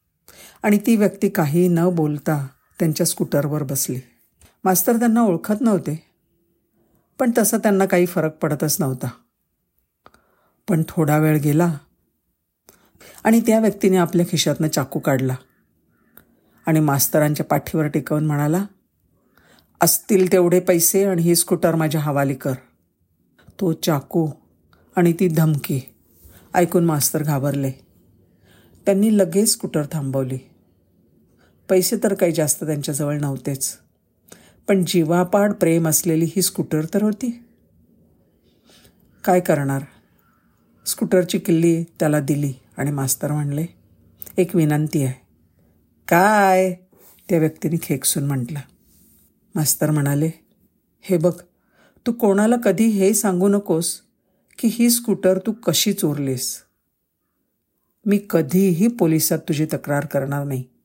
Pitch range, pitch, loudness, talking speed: 140-185 Hz, 160 Hz, -19 LUFS, 110 wpm